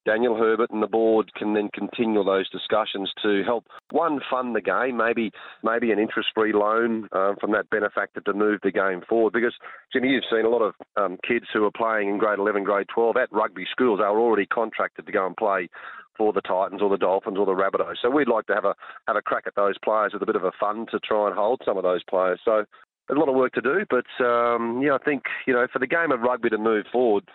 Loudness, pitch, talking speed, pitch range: -23 LUFS, 110 Hz, 255 wpm, 105-120 Hz